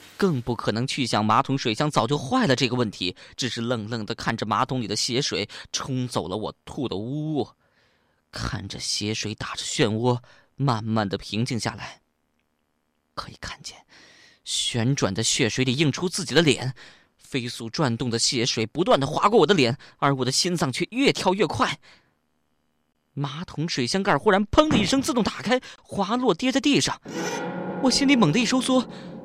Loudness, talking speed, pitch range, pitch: -24 LUFS, 250 characters per minute, 110-170 Hz, 130 Hz